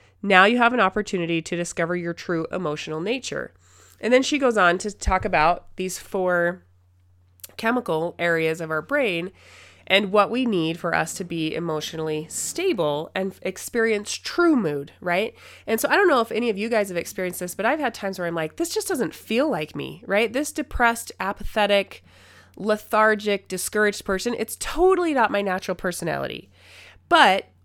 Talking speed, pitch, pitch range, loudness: 175 wpm, 190 Hz, 165-225 Hz, -23 LUFS